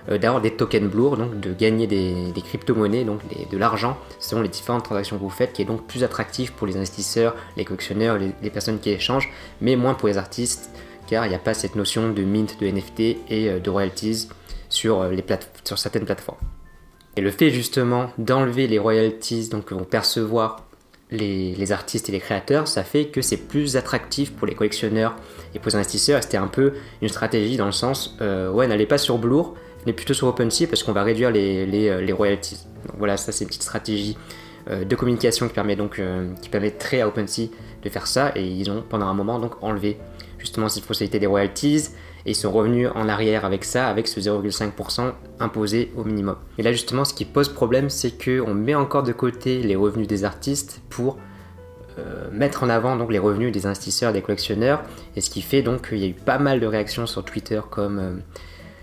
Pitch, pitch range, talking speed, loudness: 110 Hz, 100-120 Hz, 215 wpm, -23 LUFS